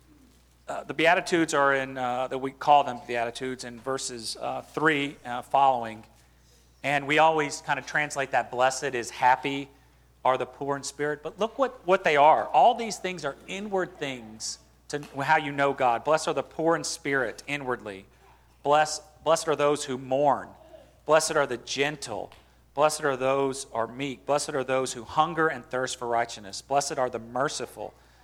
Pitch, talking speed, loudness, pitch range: 135 Hz, 180 wpm, -26 LUFS, 120-150 Hz